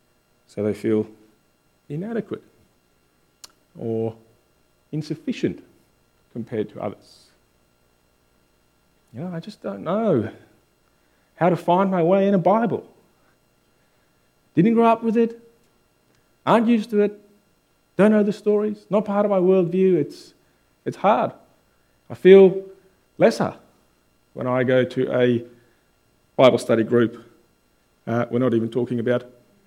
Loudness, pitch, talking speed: -20 LUFS, 120 Hz, 125 wpm